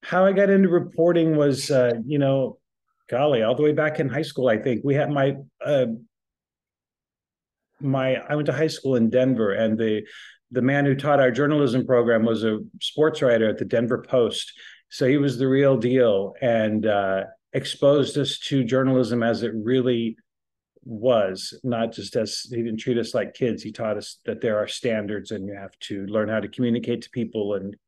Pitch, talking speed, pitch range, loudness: 125 Hz, 195 wpm, 110-140 Hz, -22 LUFS